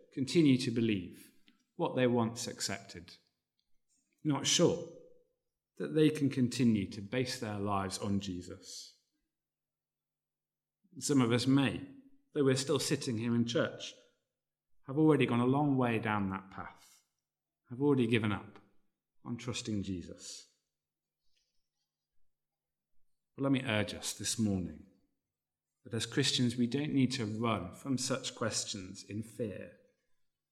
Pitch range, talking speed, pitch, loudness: 105-135 Hz, 130 wpm, 120 Hz, -33 LUFS